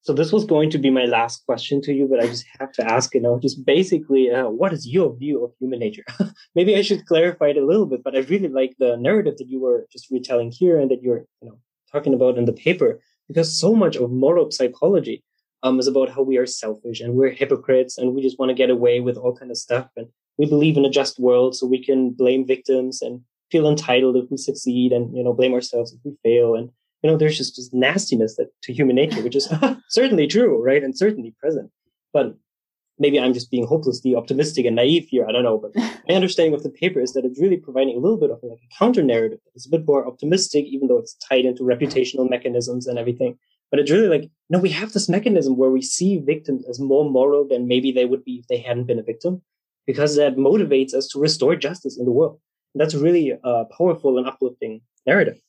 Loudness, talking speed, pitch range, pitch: -20 LUFS, 240 wpm, 125-155 Hz, 130 Hz